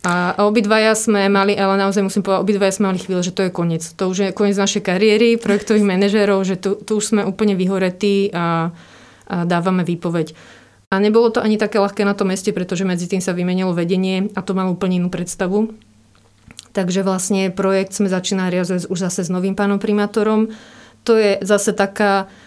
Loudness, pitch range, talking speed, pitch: -17 LUFS, 185-205 Hz, 190 wpm, 195 Hz